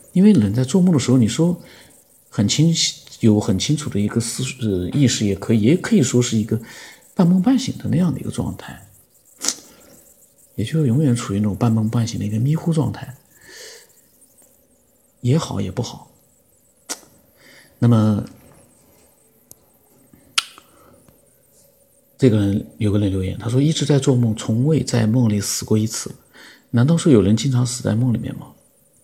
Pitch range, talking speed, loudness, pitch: 110-145 Hz, 225 characters per minute, -19 LUFS, 120 Hz